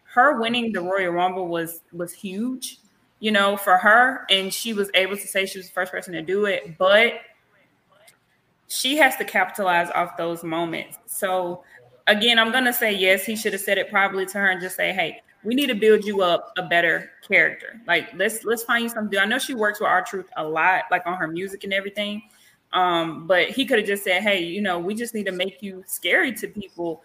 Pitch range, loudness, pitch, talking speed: 180-220 Hz, -21 LUFS, 195 Hz, 230 wpm